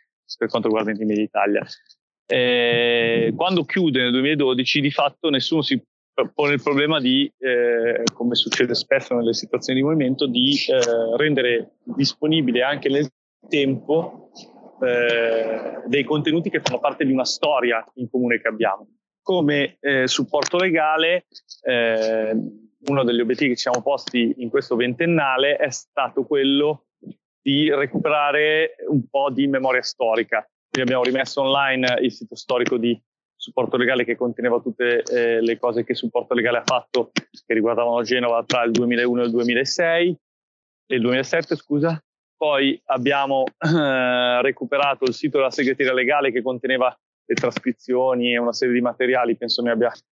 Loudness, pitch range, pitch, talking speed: -20 LUFS, 120-145 Hz, 130 Hz, 150 wpm